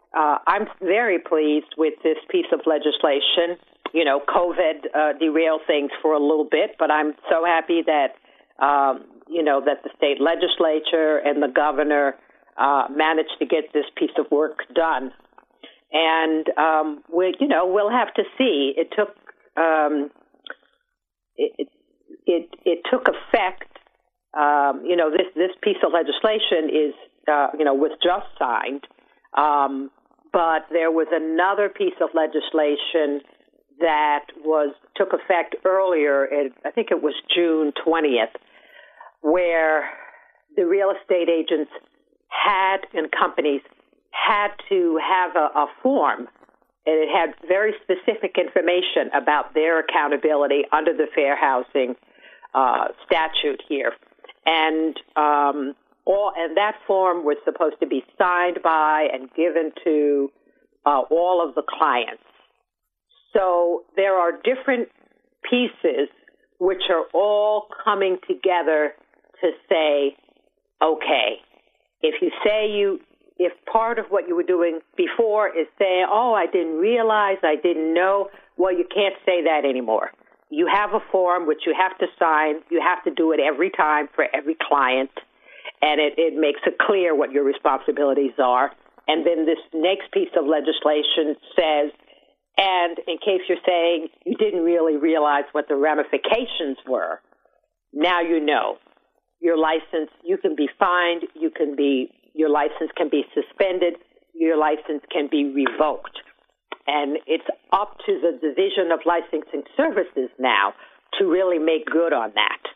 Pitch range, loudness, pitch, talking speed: 150-195 Hz, -21 LUFS, 165 Hz, 145 wpm